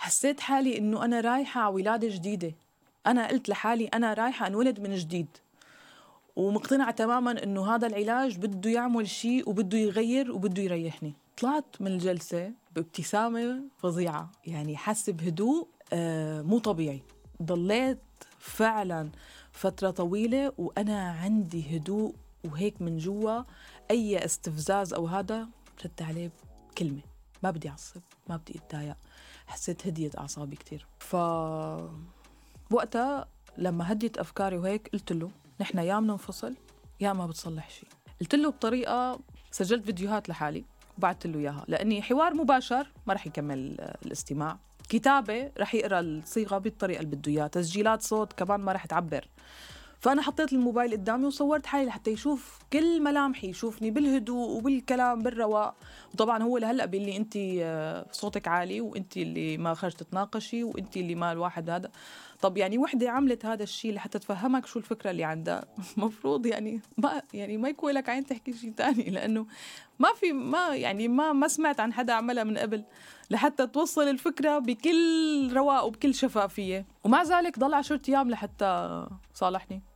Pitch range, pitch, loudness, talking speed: 180-245 Hz, 215 Hz, -29 LUFS, 145 wpm